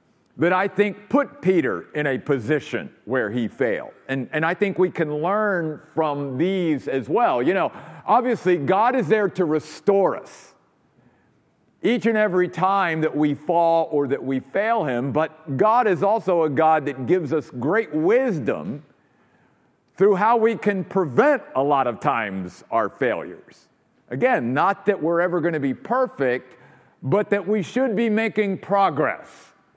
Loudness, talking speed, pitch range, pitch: -22 LUFS, 165 wpm, 155-205 Hz, 180 Hz